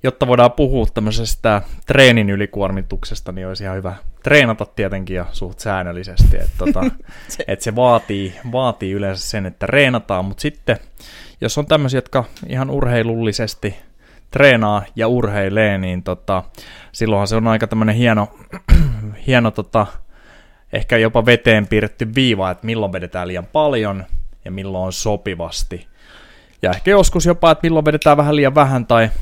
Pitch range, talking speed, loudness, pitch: 95-125 Hz, 140 wpm, -16 LUFS, 110 Hz